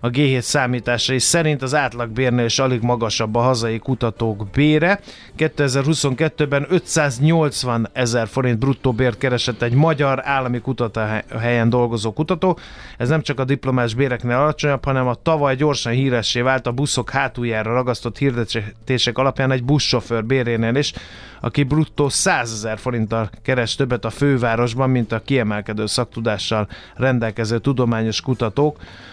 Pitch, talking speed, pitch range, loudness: 125 Hz, 135 wpm, 115-140 Hz, -19 LUFS